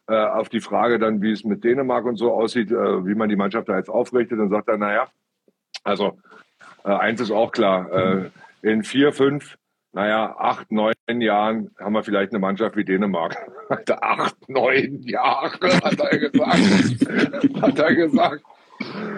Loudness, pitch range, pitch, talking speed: -20 LUFS, 105-120 Hz, 110 Hz, 155 wpm